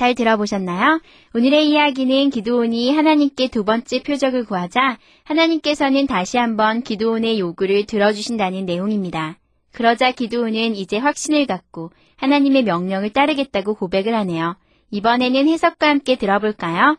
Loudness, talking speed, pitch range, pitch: -18 LUFS, 370 characters per minute, 205-275 Hz, 235 Hz